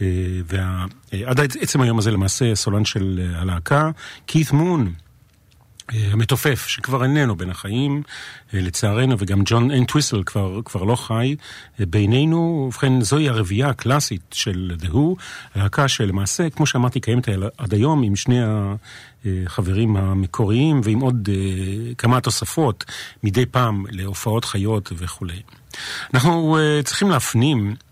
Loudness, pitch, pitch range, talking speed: -20 LUFS, 115 Hz, 100-130 Hz, 120 wpm